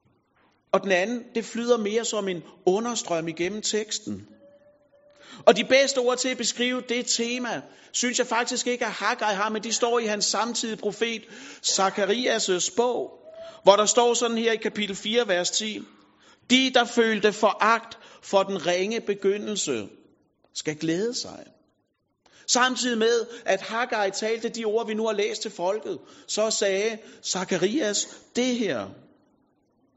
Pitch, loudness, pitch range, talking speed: 225 Hz, -24 LUFS, 200-240 Hz, 150 wpm